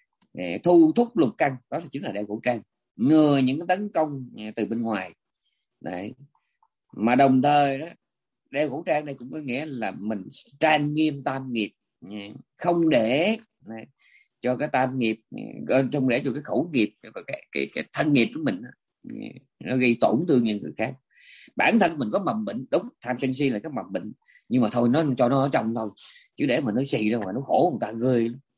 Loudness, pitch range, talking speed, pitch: -24 LUFS, 110-145 Hz, 215 wpm, 130 Hz